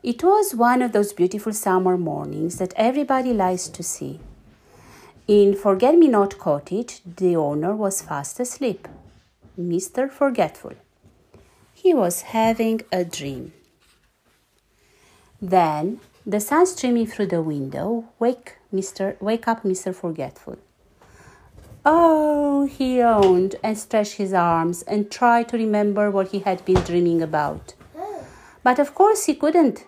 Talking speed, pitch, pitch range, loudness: 130 wpm, 210 Hz, 185-245 Hz, -21 LUFS